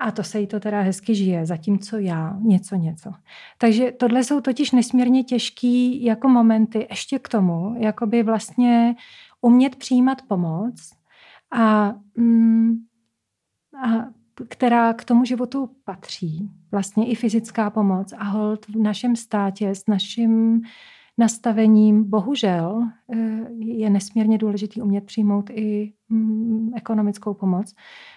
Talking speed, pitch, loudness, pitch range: 120 wpm, 225 Hz, -20 LUFS, 205-235 Hz